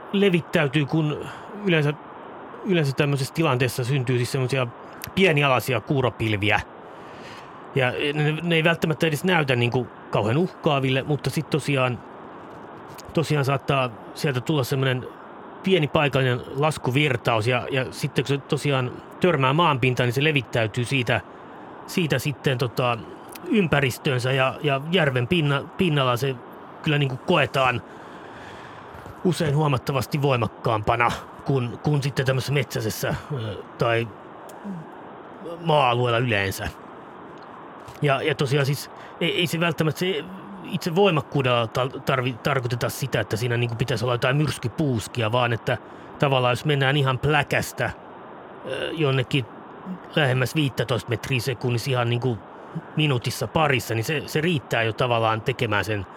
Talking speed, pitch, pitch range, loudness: 125 wpm, 135 Hz, 125-155 Hz, -23 LUFS